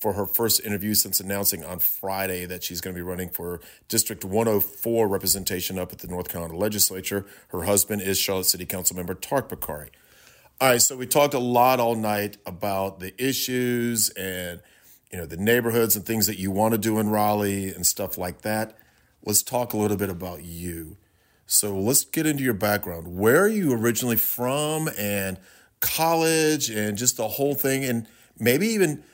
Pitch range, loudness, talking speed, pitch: 95-120 Hz, -23 LUFS, 185 wpm, 105 Hz